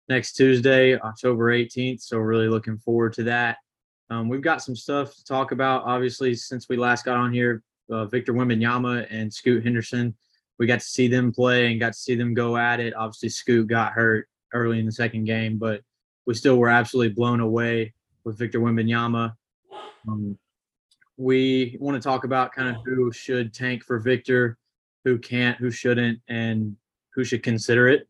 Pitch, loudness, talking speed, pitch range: 120 Hz, -23 LUFS, 185 wpm, 115-125 Hz